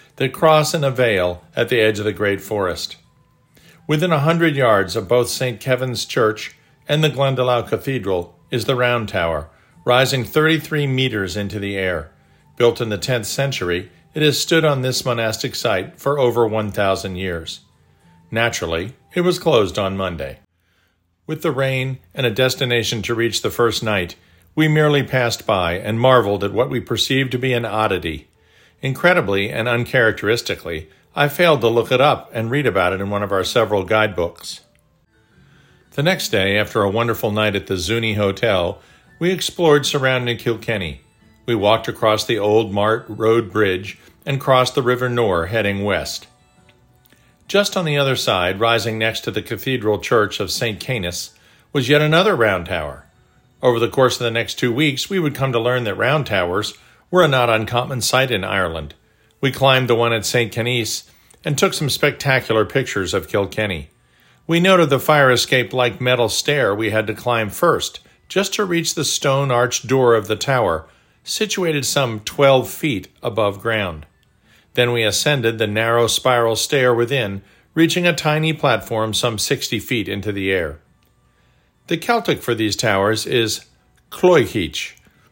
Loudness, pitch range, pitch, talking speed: -18 LUFS, 105-135 Hz, 120 Hz, 170 wpm